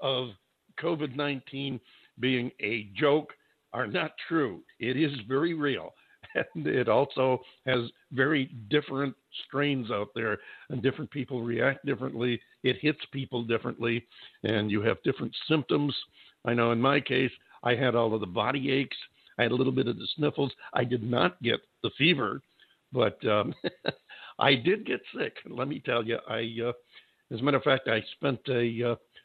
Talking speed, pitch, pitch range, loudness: 170 wpm, 130 Hz, 120-140 Hz, -29 LUFS